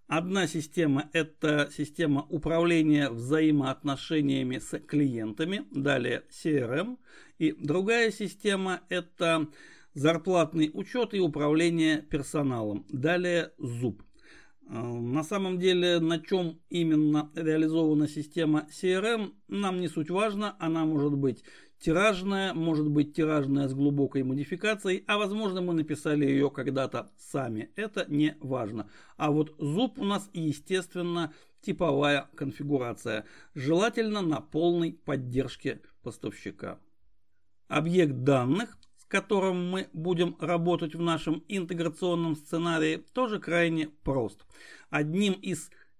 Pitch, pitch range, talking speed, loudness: 160 Hz, 145-180 Hz, 110 wpm, -29 LUFS